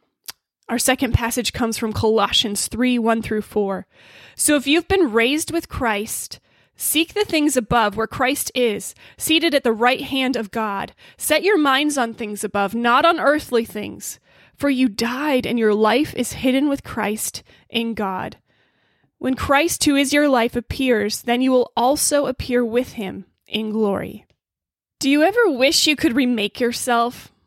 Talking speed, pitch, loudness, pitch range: 170 wpm, 245 Hz, -19 LUFS, 225-285 Hz